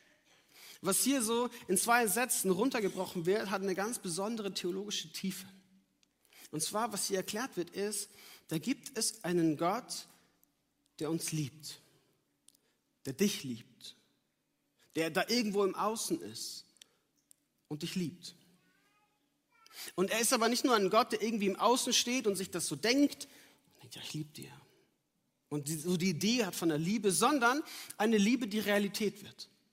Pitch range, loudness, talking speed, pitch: 175-230 Hz, -33 LUFS, 160 wpm, 195 Hz